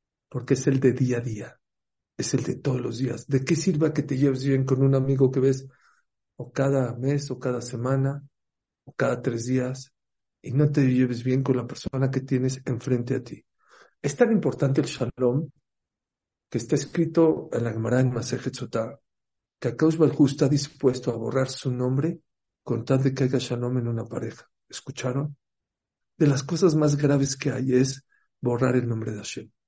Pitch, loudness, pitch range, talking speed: 130 Hz, -25 LUFS, 125-140 Hz, 190 wpm